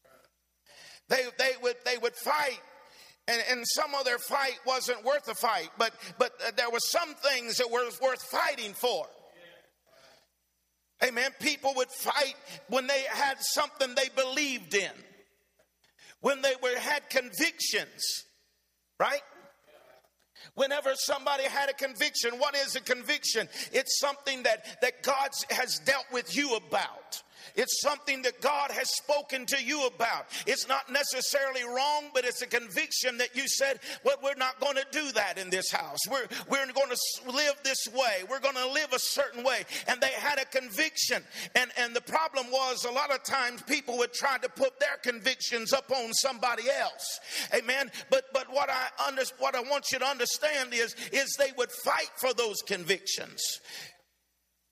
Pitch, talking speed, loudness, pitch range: 265 Hz, 170 wpm, -29 LUFS, 245-275 Hz